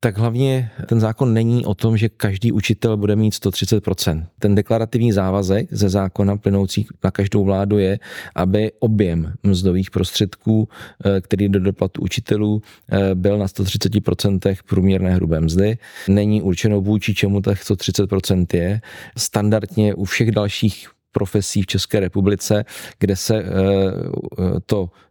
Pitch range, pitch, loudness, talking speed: 95-110 Hz, 100 Hz, -19 LUFS, 130 wpm